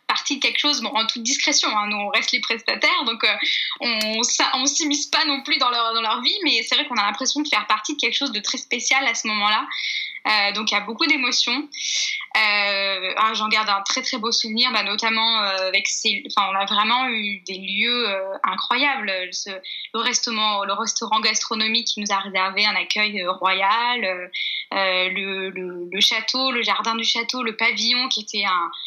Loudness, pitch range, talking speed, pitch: -20 LUFS, 205-255 Hz, 210 wpm, 225 Hz